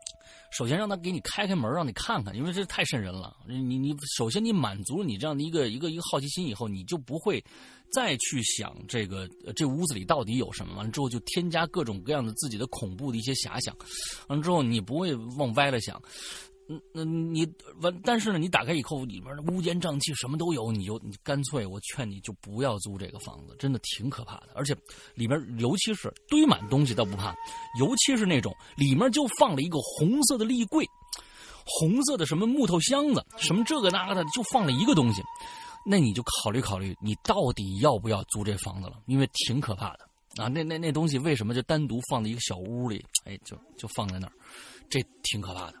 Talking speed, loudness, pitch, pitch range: 325 characters per minute, -28 LUFS, 140 Hz, 115-175 Hz